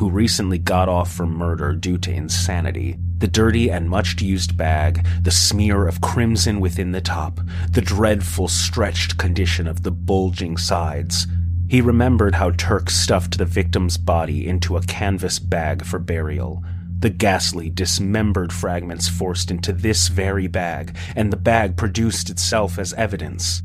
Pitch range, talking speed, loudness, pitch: 85-95 Hz, 150 wpm, -20 LUFS, 90 Hz